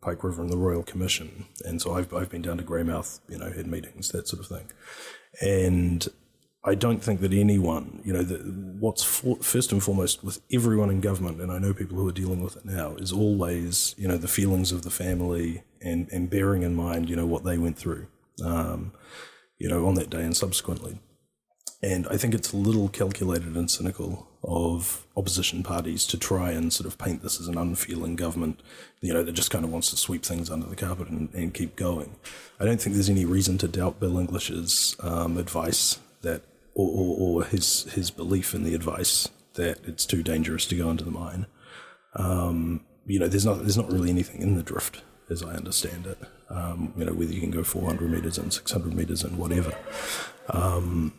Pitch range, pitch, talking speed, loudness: 85-95 Hz, 90 Hz, 210 wpm, -27 LUFS